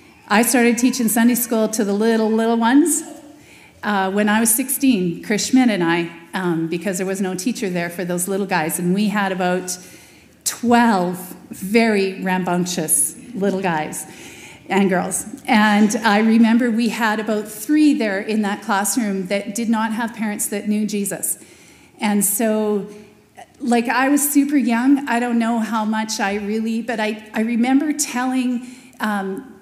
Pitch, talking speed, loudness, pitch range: 215 Hz, 160 wpm, -18 LUFS, 195-235 Hz